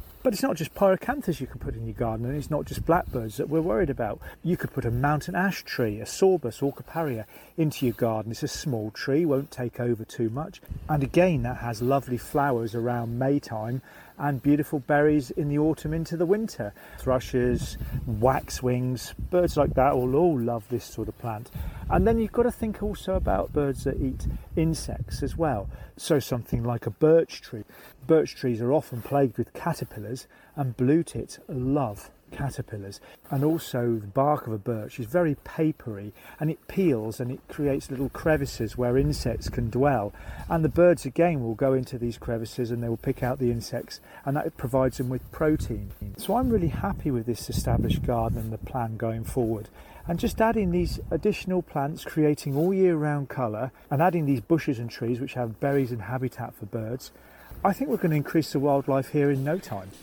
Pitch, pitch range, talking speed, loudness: 135 Hz, 120-155 Hz, 200 wpm, -27 LUFS